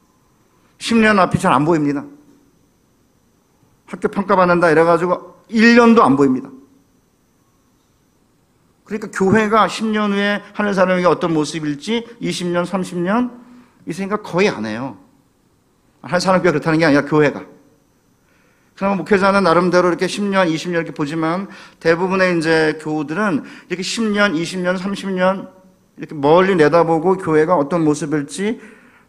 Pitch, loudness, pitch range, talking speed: 180 Hz, -16 LUFS, 160-205 Hz, 270 characters per minute